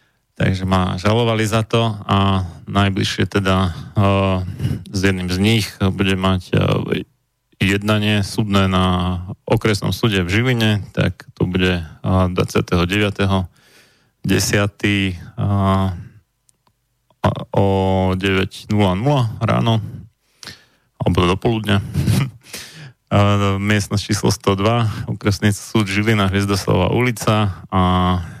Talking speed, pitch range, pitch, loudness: 95 wpm, 95-115 Hz, 100 Hz, -18 LUFS